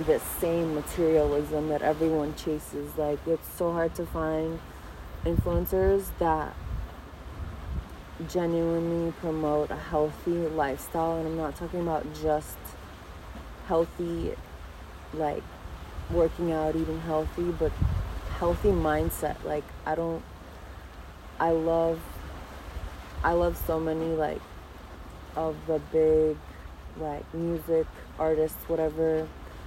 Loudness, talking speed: -29 LUFS, 105 wpm